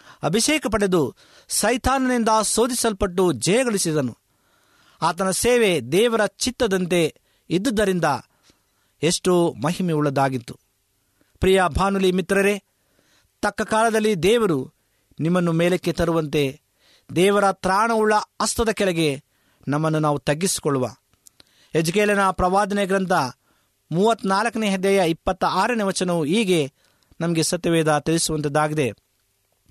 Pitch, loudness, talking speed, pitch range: 180 Hz, -21 LUFS, 85 wpm, 150-205 Hz